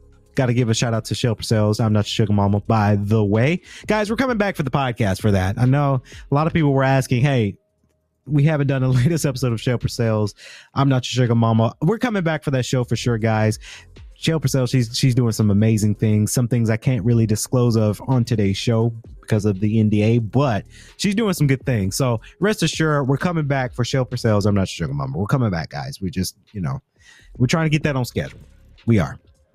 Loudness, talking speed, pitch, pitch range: -20 LUFS, 240 wpm, 120 Hz, 105-140 Hz